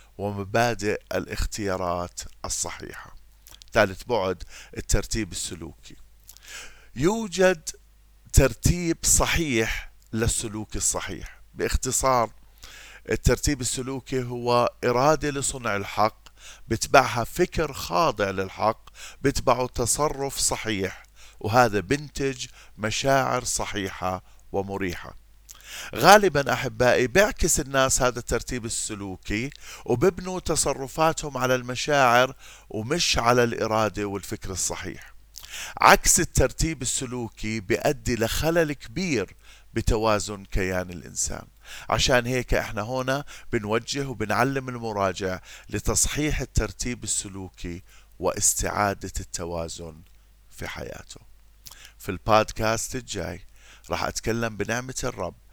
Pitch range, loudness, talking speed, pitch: 100-130 Hz, -24 LUFS, 85 wpm, 115 Hz